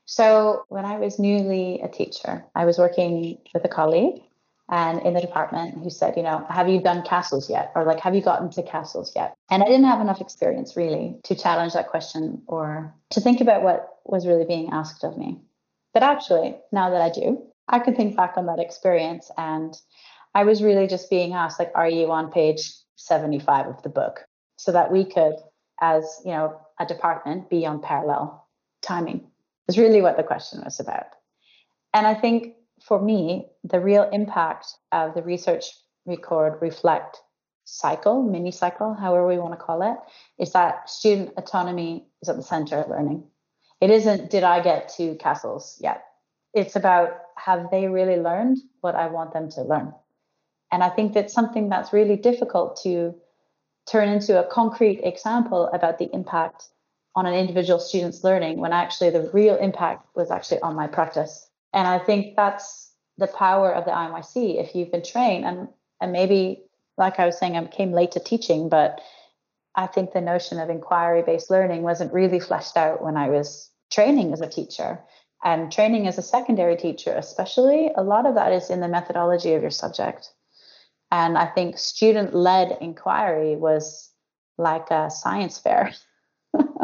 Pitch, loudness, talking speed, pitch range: 175 Hz, -22 LUFS, 180 wpm, 165-200 Hz